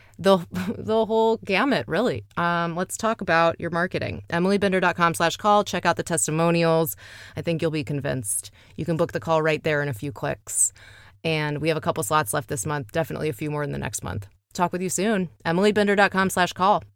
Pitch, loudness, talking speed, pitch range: 165 Hz, -23 LUFS, 205 wpm, 150-185 Hz